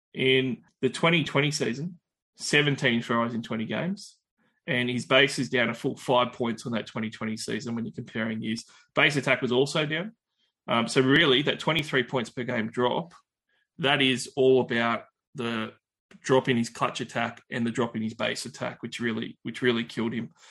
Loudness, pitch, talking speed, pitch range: -26 LUFS, 125 Hz, 185 wpm, 115-140 Hz